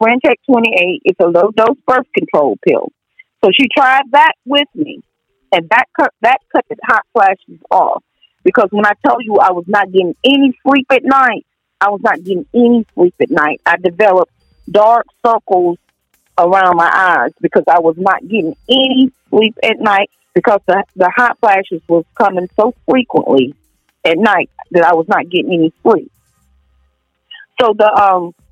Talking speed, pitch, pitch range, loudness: 175 wpm, 210 Hz, 180-255 Hz, -12 LUFS